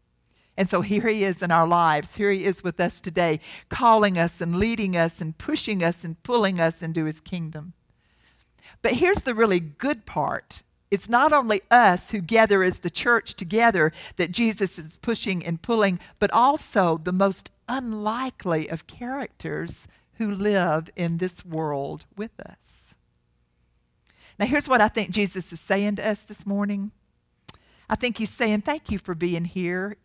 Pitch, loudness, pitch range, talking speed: 195 Hz, -23 LUFS, 170-220 Hz, 170 wpm